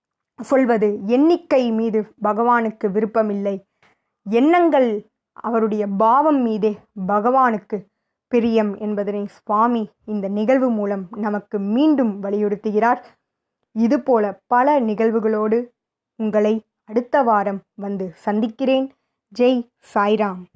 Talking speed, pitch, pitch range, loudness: 85 wpm, 220 Hz, 210-240 Hz, -19 LUFS